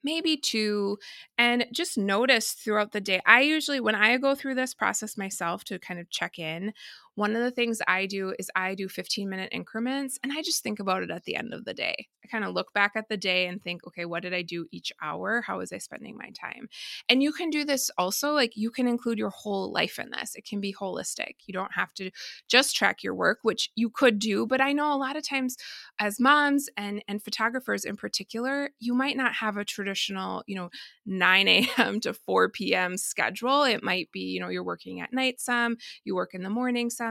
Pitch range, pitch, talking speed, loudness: 195-260 Hz, 220 Hz, 235 wpm, -27 LUFS